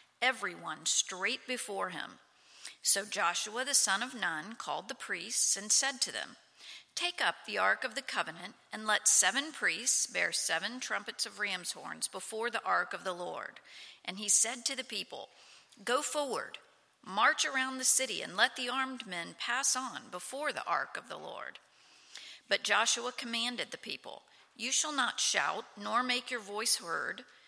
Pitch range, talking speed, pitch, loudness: 210-260 Hz, 175 wpm, 240 Hz, -32 LUFS